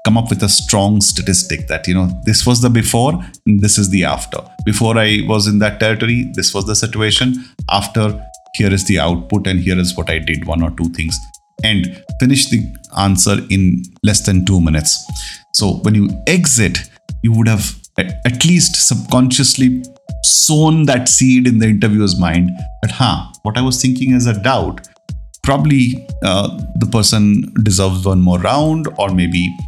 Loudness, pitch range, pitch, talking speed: -13 LUFS, 90-125 Hz, 105 Hz, 180 wpm